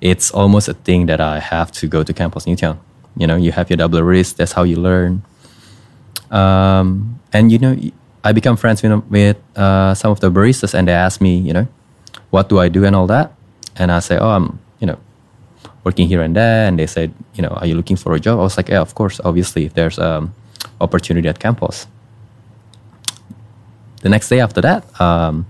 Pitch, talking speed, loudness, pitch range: 95 Hz, 215 wpm, -14 LUFS, 85-110 Hz